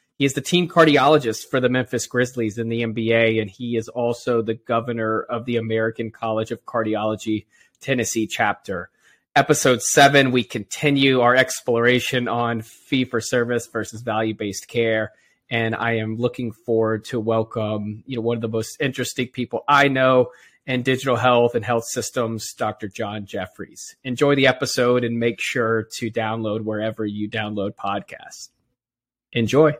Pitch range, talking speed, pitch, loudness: 110-125 Hz, 160 wpm, 120 Hz, -21 LUFS